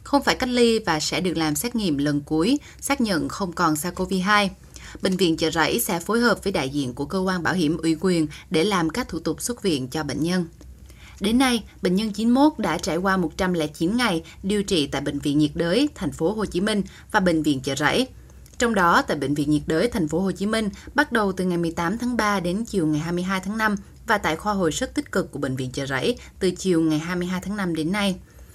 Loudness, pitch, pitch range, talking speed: -23 LUFS, 180 Hz, 155-210 Hz, 245 wpm